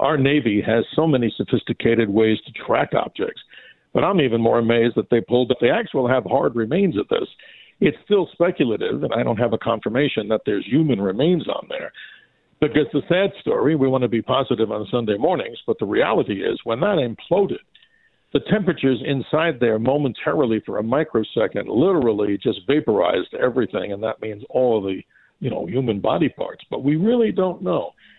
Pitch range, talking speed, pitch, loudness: 115-160 Hz, 185 wpm, 130 Hz, -20 LUFS